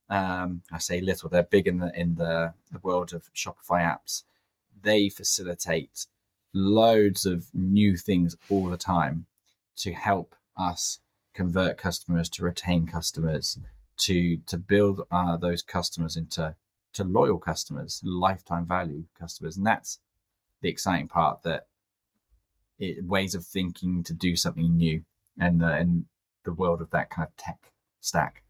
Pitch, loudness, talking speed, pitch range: 90 Hz, -27 LUFS, 150 wpm, 85-95 Hz